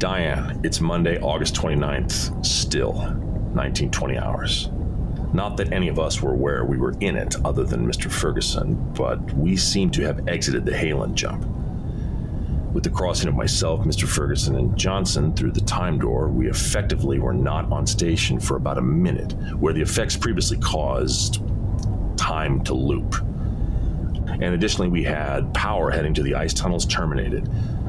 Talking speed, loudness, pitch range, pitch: 160 wpm, -23 LUFS, 75-105 Hz, 85 Hz